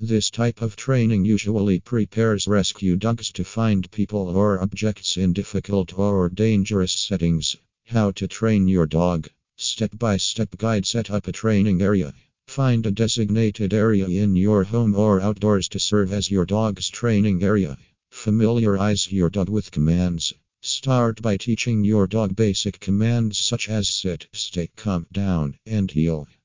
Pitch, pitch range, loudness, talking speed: 100 Hz, 95-110 Hz, -21 LUFS, 155 wpm